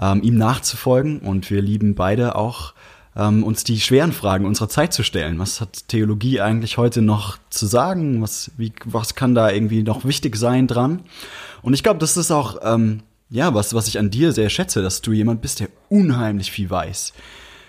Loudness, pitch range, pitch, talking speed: -19 LUFS, 105-130 Hz, 110 Hz, 190 wpm